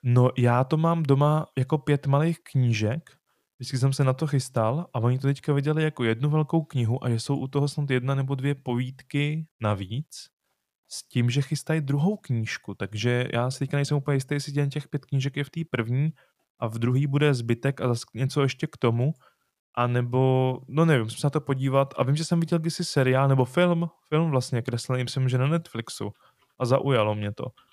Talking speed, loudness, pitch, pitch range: 210 wpm, -26 LUFS, 135 Hz, 125-150 Hz